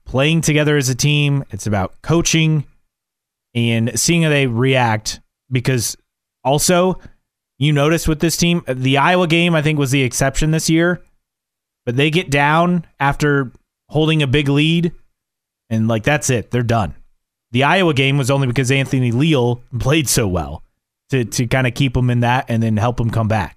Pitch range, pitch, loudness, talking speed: 120-155 Hz, 135 Hz, -16 LUFS, 180 wpm